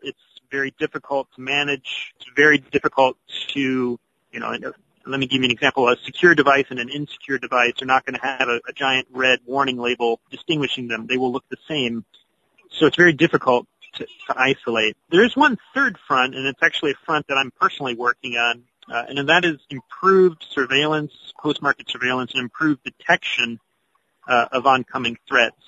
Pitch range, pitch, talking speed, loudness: 125-145 Hz, 135 Hz, 185 wpm, -20 LUFS